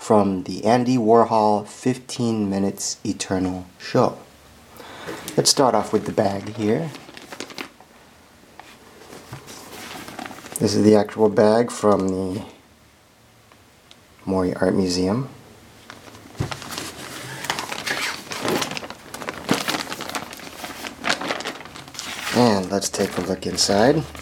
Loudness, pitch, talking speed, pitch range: -22 LUFS, 105 Hz, 75 wpm, 95-110 Hz